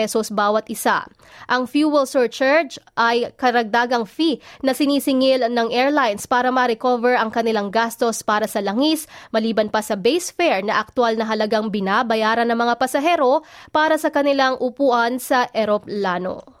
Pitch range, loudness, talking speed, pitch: 220-270 Hz, -19 LUFS, 145 wpm, 240 Hz